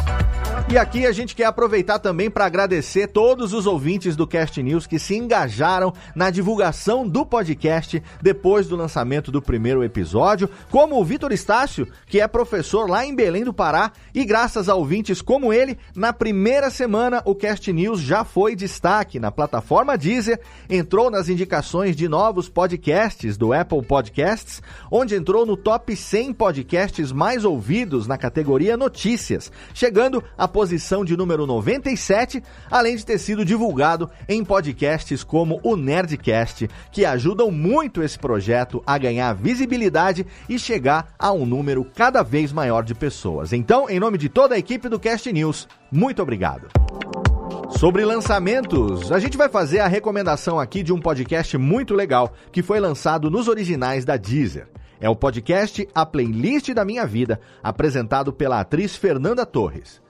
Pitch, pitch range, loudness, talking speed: 185 Hz, 145-220 Hz, -20 LUFS, 160 wpm